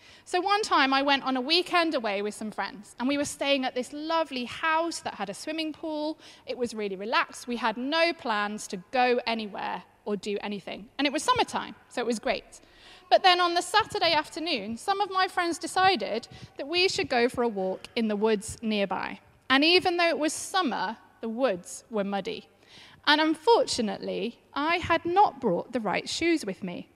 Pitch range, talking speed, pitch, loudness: 225-340 Hz, 200 wpm, 285 Hz, -27 LUFS